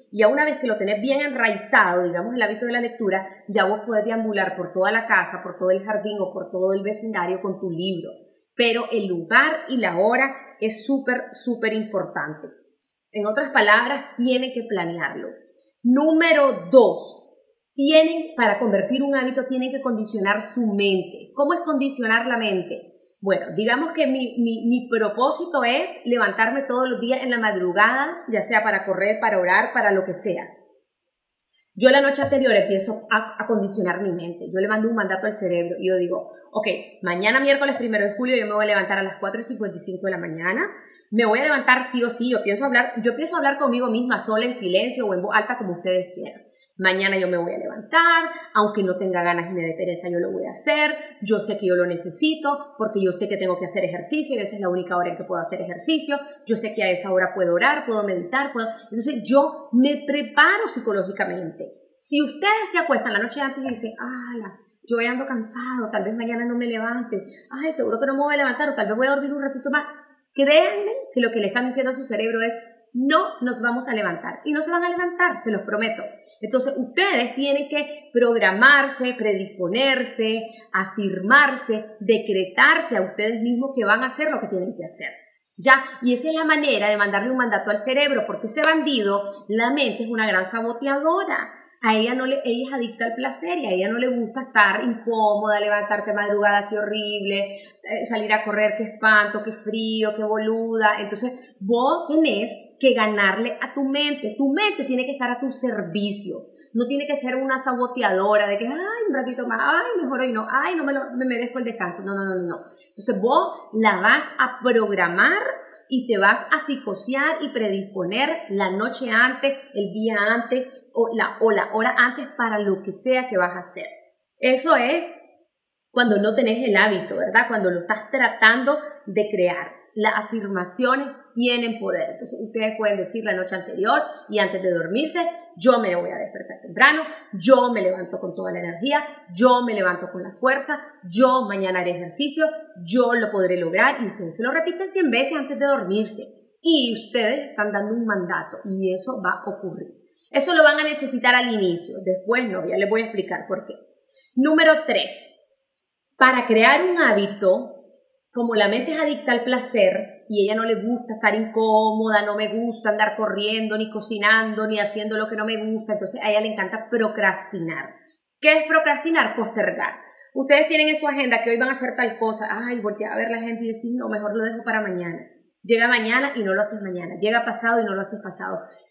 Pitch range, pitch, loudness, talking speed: 205-270 Hz, 230 Hz, -21 LUFS, 200 wpm